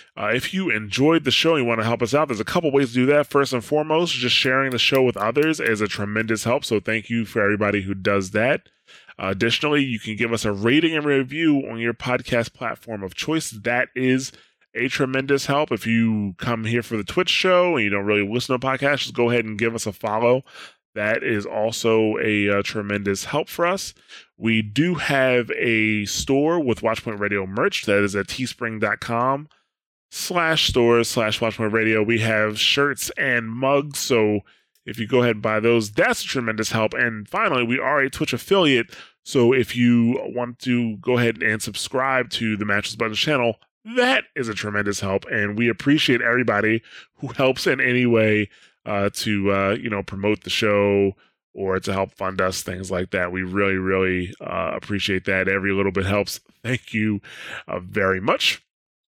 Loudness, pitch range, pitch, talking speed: -21 LUFS, 105-130 Hz, 115 Hz, 200 wpm